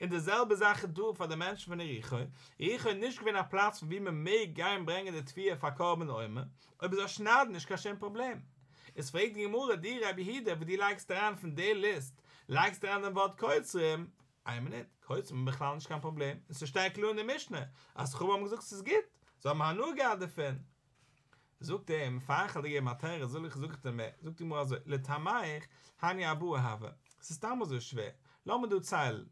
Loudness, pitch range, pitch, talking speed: -35 LUFS, 140-200 Hz, 165 Hz, 200 wpm